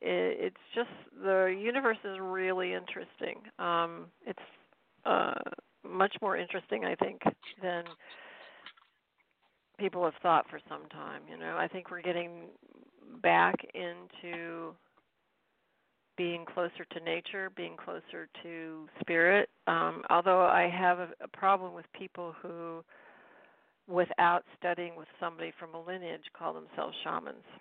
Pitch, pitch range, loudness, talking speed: 175 Hz, 170-190 Hz, -32 LUFS, 125 wpm